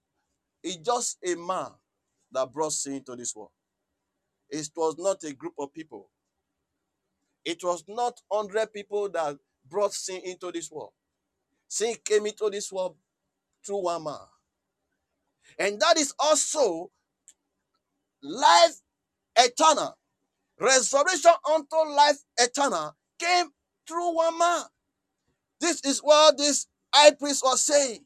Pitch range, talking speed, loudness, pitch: 180-300 Hz, 125 wpm, -24 LUFS, 235 Hz